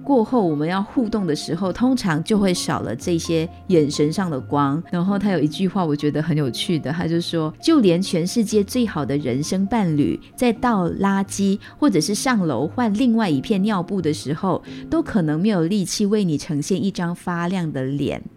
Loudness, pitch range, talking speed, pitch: -21 LUFS, 155-210 Hz, 290 characters per minute, 175 Hz